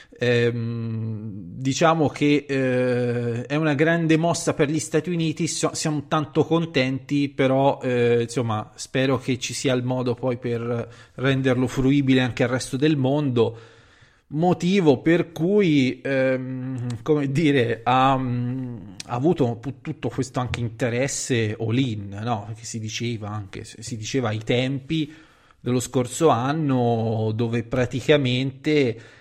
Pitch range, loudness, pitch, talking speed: 120-145 Hz, -23 LUFS, 130 Hz, 130 wpm